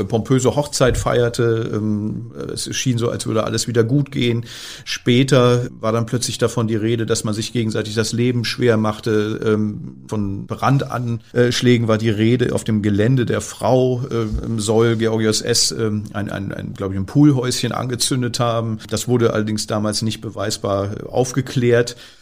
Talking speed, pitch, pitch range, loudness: 155 wpm, 115 Hz, 110-120 Hz, -19 LUFS